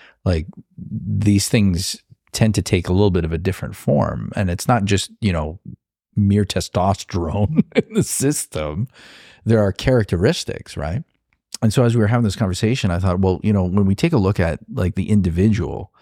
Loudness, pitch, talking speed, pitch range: -19 LUFS, 100 Hz, 185 wpm, 95-110 Hz